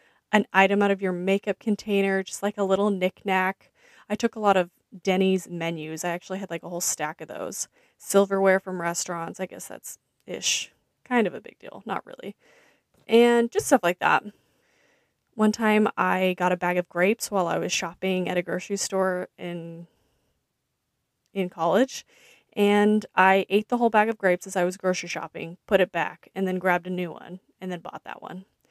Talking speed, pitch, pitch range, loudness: 195 wpm, 190 Hz, 180-210 Hz, -25 LUFS